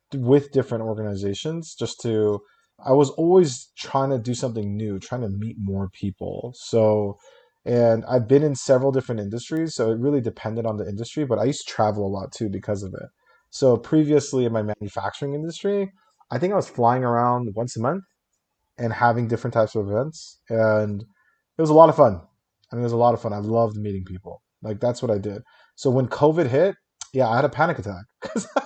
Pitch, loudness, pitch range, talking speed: 120 Hz, -22 LUFS, 105-140 Hz, 210 wpm